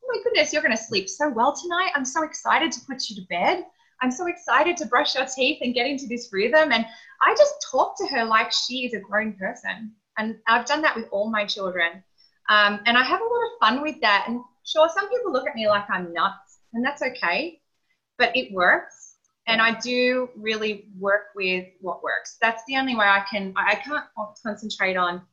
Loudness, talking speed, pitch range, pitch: -23 LUFS, 220 wpm, 205-290 Hz, 230 Hz